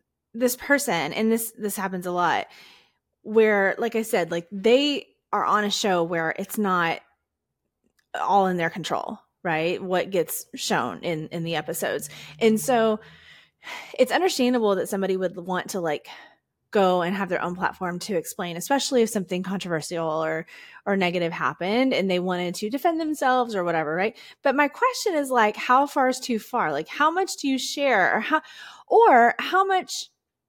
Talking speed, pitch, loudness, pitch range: 175 wpm, 210 Hz, -24 LUFS, 180-255 Hz